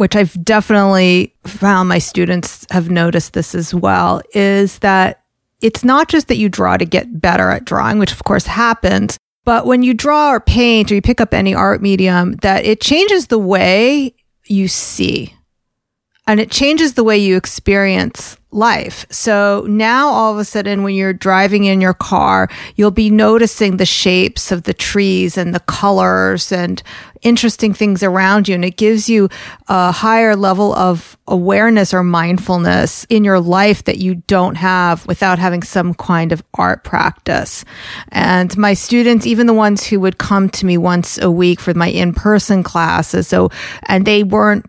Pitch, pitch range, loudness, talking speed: 195 Hz, 180-215 Hz, -13 LUFS, 175 wpm